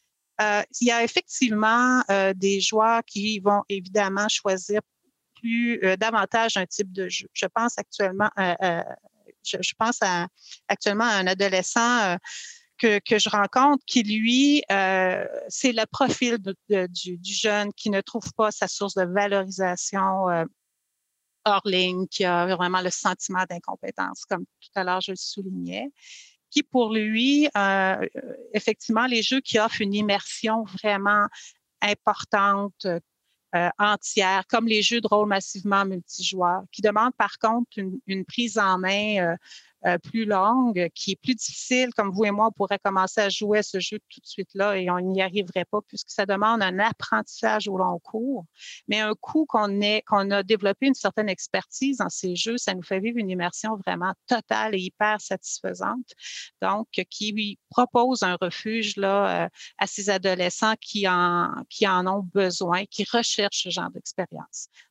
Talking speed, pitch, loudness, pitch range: 165 wpm, 205 Hz, -24 LUFS, 190-225 Hz